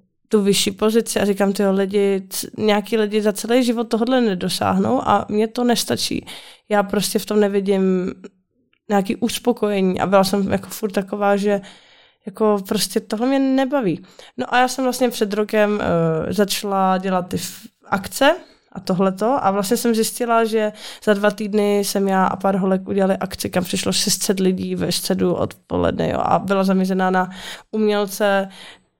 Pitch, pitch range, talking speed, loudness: 205 Hz, 195-220 Hz, 165 wpm, -19 LUFS